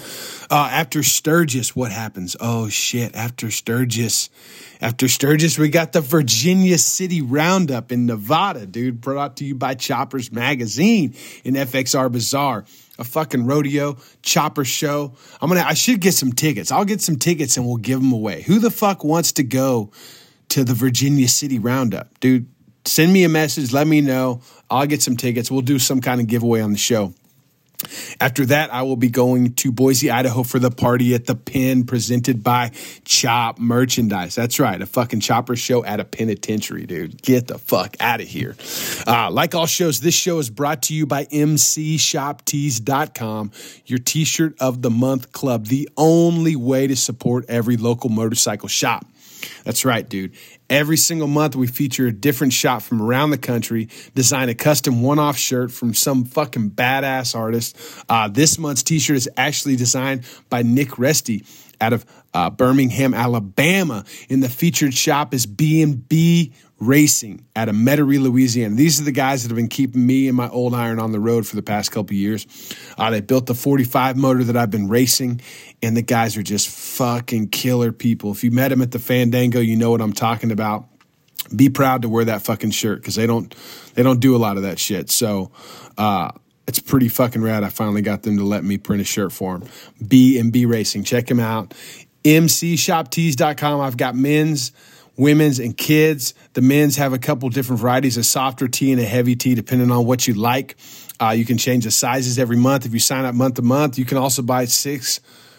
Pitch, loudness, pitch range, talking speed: 130 Hz, -18 LUFS, 120-145 Hz, 195 wpm